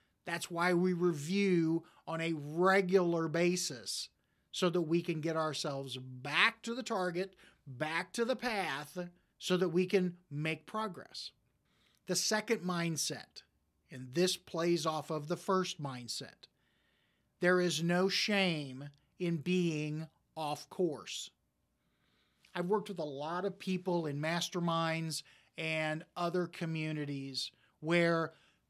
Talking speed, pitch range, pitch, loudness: 125 wpm, 150-180 Hz, 170 Hz, -35 LUFS